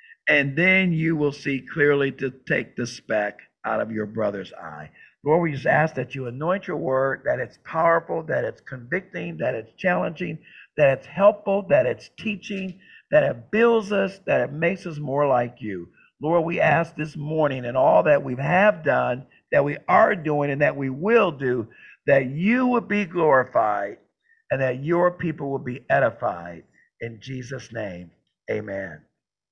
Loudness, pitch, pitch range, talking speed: -23 LUFS, 150 Hz, 130-185 Hz, 175 wpm